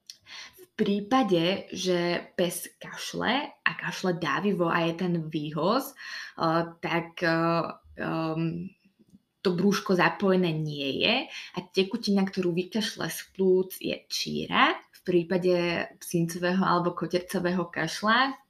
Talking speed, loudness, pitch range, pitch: 105 wpm, -27 LUFS, 170-190 Hz, 180 Hz